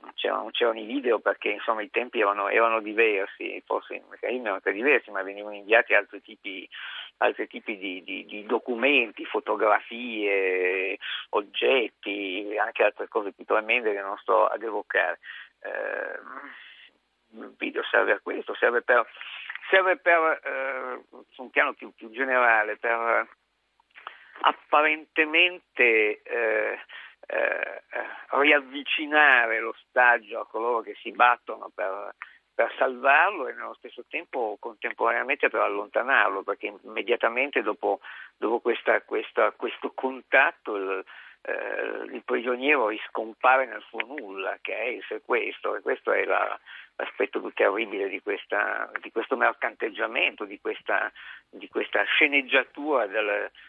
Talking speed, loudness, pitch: 130 wpm, -25 LUFS, 185 Hz